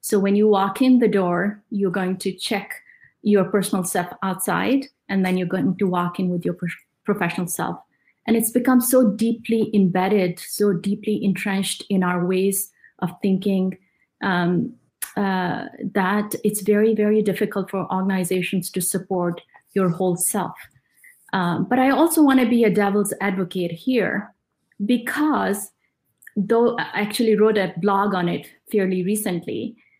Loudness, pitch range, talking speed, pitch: -21 LUFS, 185-220 Hz, 155 wpm, 200 Hz